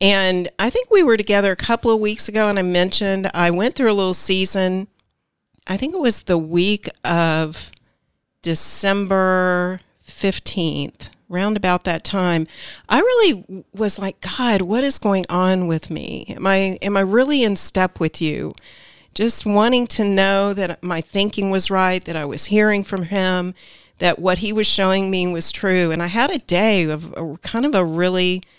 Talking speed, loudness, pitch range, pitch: 185 wpm, -18 LUFS, 180-210 Hz, 190 Hz